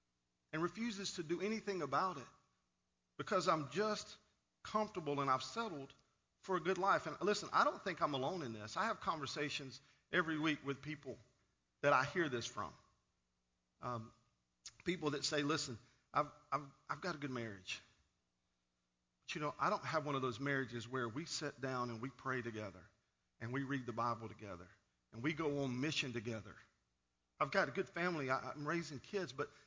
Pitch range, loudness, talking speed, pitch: 110-160 Hz, -41 LUFS, 185 wpm, 135 Hz